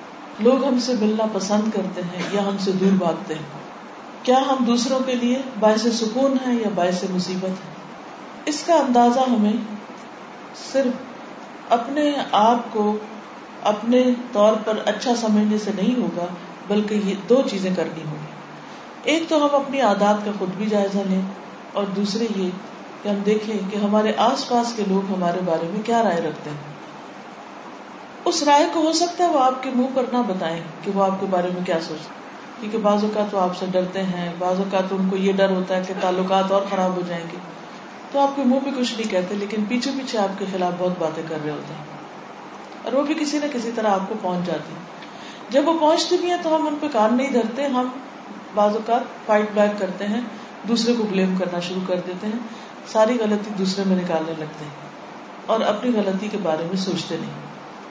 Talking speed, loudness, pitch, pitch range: 195 wpm, -21 LUFS, 210 Hz, 190-245 Hz